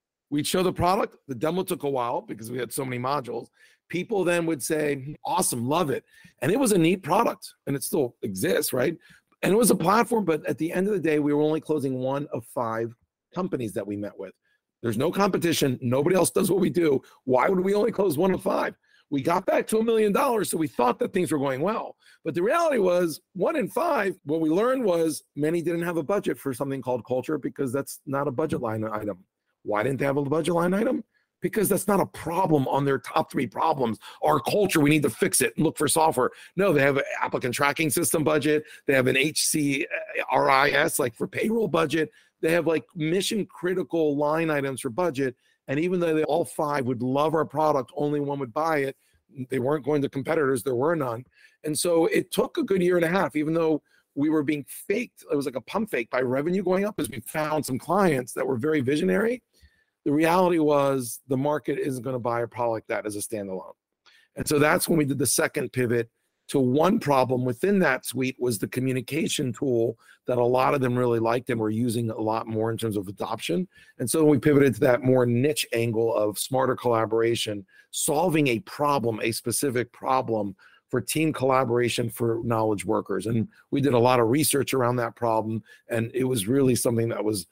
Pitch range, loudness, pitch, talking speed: 125-165 Hz, -25 LUFS, 145 Hz, 220 wpm